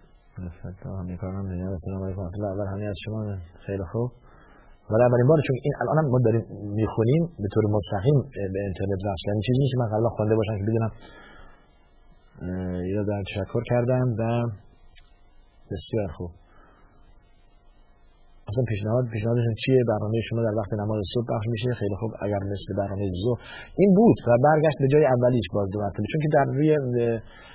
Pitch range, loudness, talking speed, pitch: 100-120 Hz, -25 LUFS, 165 wpm, 110 Hz